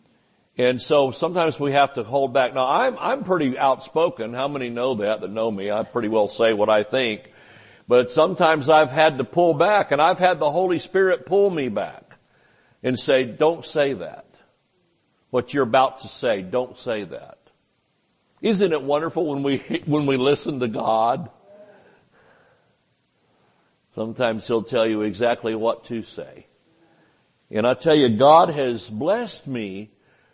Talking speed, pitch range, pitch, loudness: 160 wpm, 120-160 Hz, 135 Hz, -21 LUFS